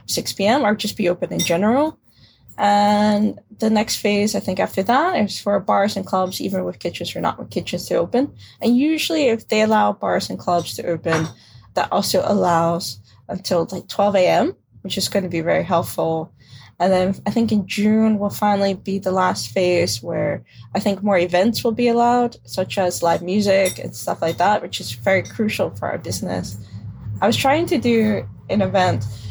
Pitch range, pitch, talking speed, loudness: 170-210 Hz, 195 Hz, 195 wpm, -19 LUFS